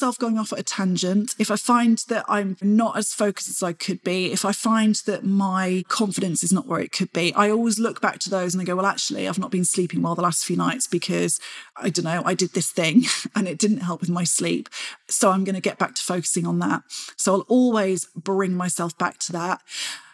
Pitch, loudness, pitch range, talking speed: 190 Hz, -22 LUFS, 180-215 Hz, 245 wpm